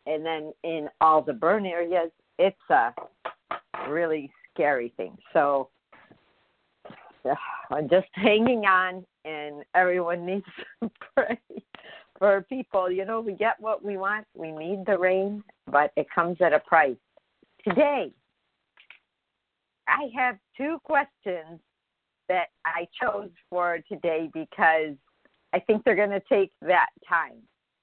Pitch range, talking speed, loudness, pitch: 160-210 Hz, 130 wpm, -26 LUFS, 185 Hz